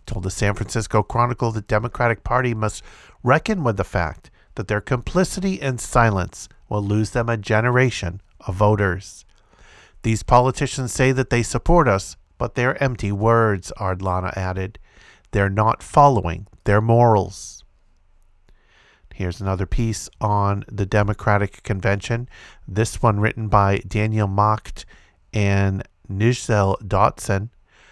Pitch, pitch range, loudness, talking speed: 105 Hz, 95-120 Hz, -21 LUFS, 125 wpm